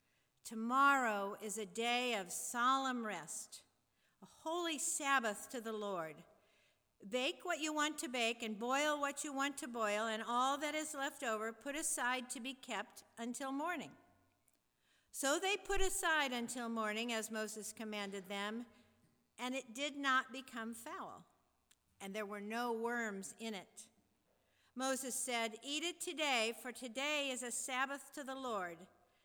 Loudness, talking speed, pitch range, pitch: -39 LUFS, 155 wpm, 220-280 Hz, 245 Hz